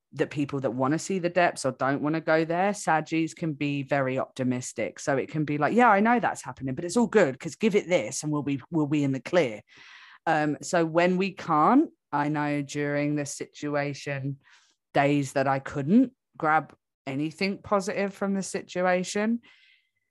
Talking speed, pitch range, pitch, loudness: 195 wpm, 140-190 Hz, 155 Hz, -26 LUFS